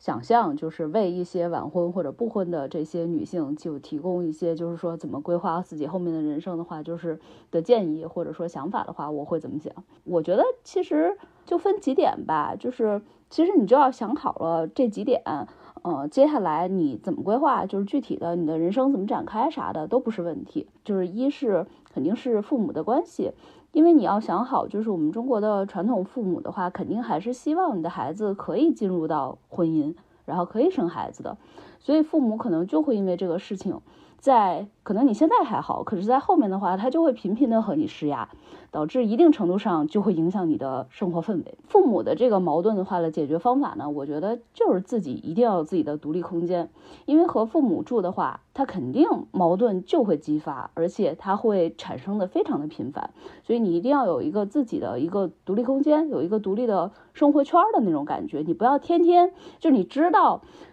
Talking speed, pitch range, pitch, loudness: 320 characters per minute, 170-275 Hz, 205 Hz, -24 LUFS